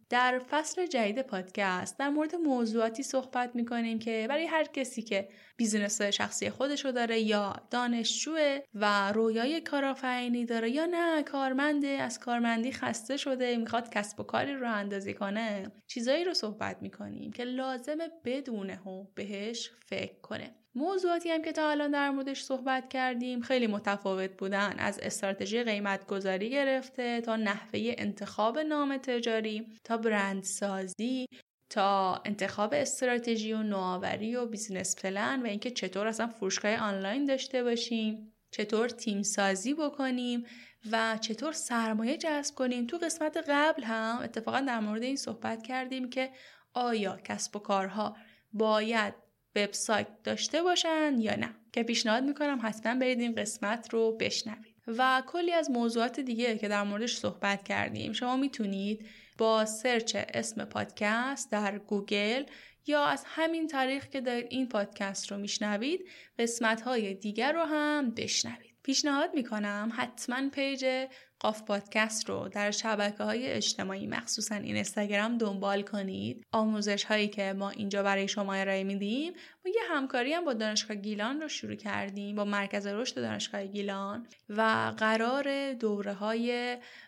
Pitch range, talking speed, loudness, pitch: 210-265 Hz, 145 wpm, -32 LUFS, 230 Hz